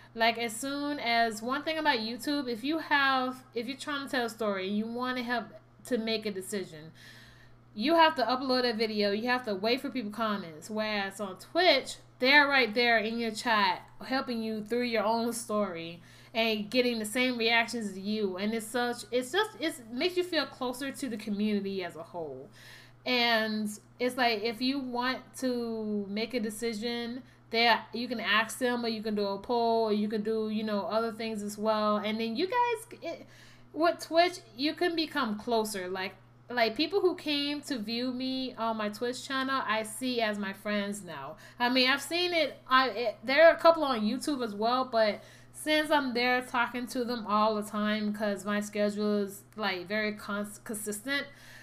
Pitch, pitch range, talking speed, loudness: 230 Hz, 210-260 Hz, 200 wpm, -30 LUFS